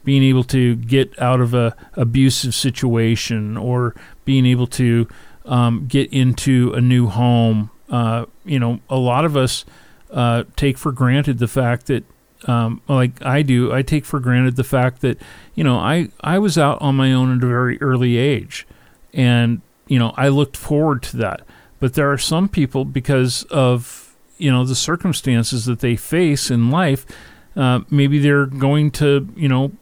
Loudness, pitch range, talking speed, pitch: -17 LUFS, 120-140 Hz, 180 wpm, 130 Hz